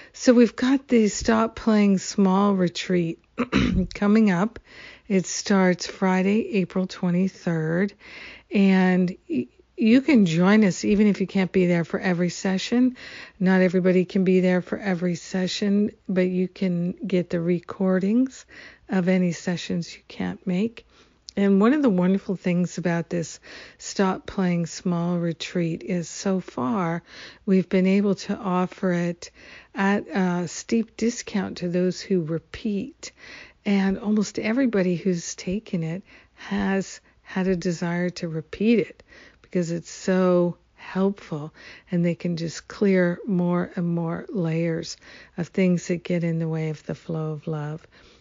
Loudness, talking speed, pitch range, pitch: -23 LUFS, 145 wpm, 175-205 Hz, 185 Hz